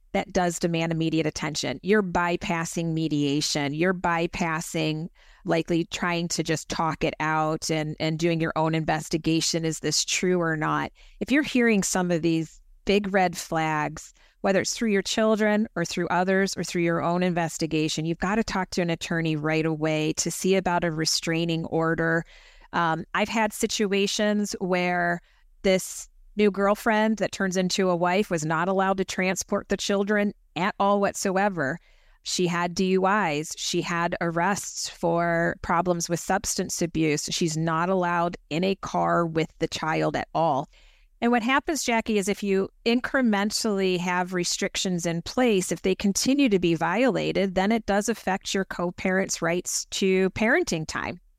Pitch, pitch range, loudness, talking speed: 175 Hz, 165-200 Hz, -25 LUFS, 160 wpm